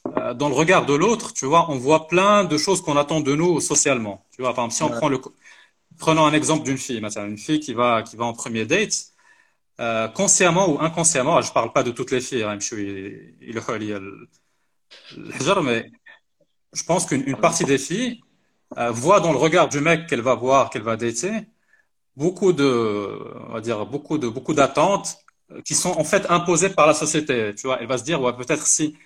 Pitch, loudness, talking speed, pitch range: 145 Hz, -20 LUFS, 195 wpm, 120-170 Hz